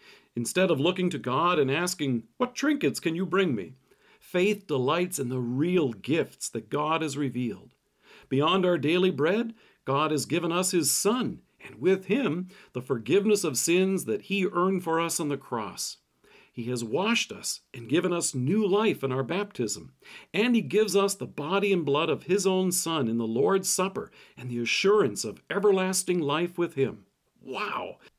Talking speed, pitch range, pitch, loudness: 180 wpm, 140-195 Hz, 175 Hz, -27 LUFS